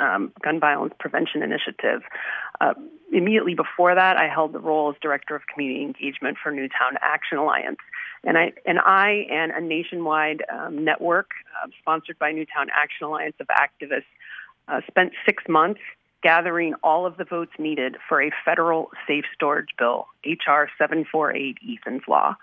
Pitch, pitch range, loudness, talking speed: 160 Hz, 150-180 Hz, -22 LUFS, 160 wpm